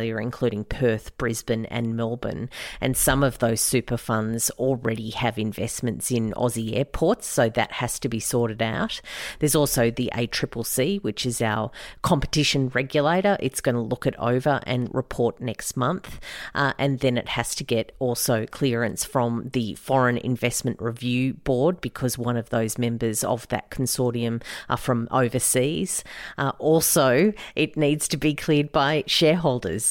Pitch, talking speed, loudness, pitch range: 125 Hz, 155 wpm, -24 LUFS, 115-135 Hz